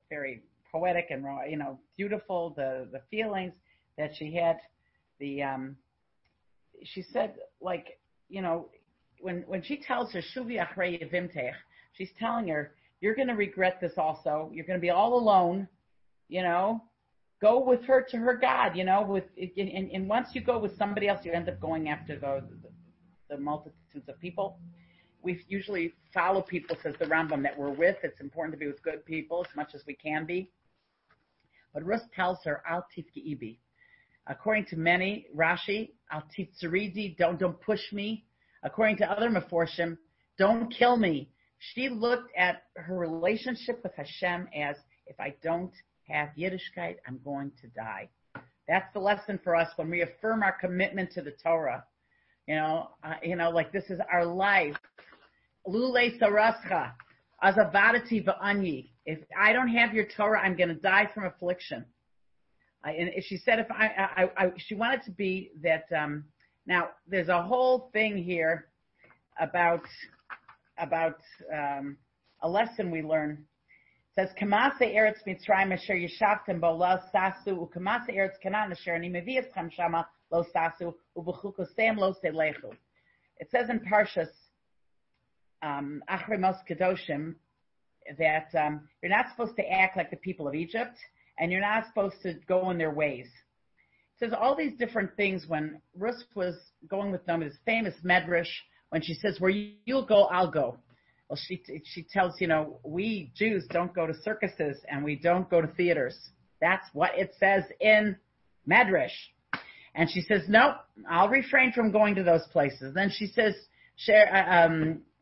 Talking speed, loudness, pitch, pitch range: 160 wpm, -29 LUFS, 180 Hz, 160-205 Hz